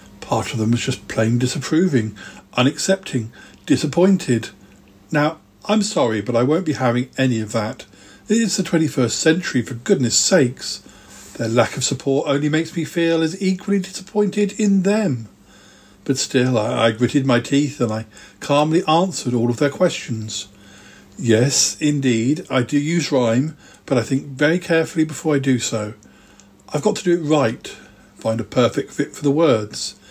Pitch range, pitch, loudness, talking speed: 115-160 Hz, 135 Hz, -19 LUFS, 165 wpm